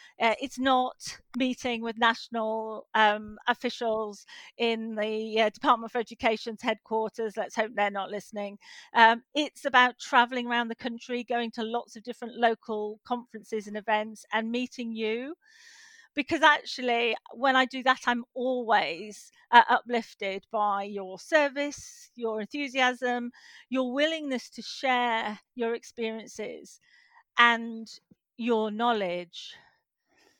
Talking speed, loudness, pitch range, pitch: 125 wpm, -28 LUFS, 220-255 Hz, 235 Hz